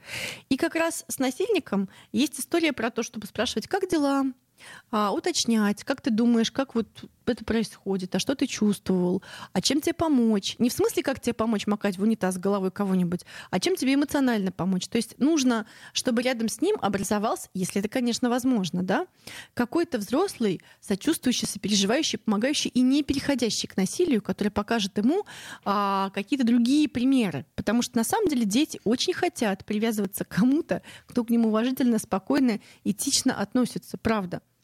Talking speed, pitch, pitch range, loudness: 165 wpm, 230 Hz, 205-275 Hz, -26 LUFS